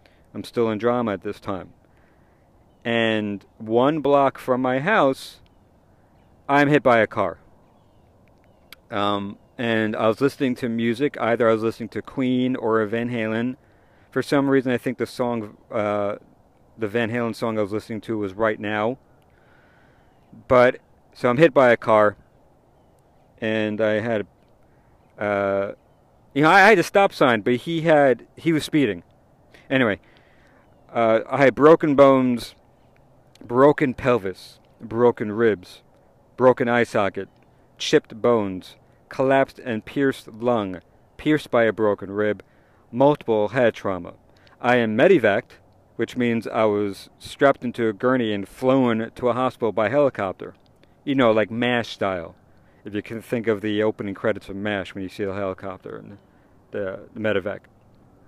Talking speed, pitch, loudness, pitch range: 150 wpm, 115 Hz, -21 LUFS, 105-125 Hz